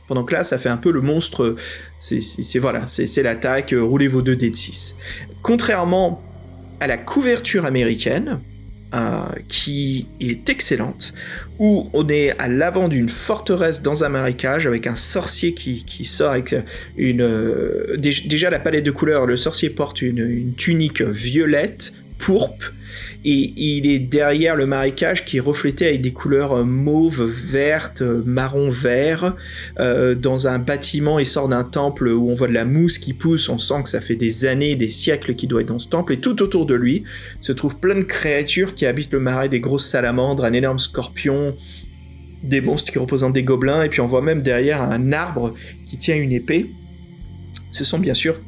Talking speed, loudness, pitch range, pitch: 185 wpm, -18 LUFS, 120-150 Hz, 130 Hz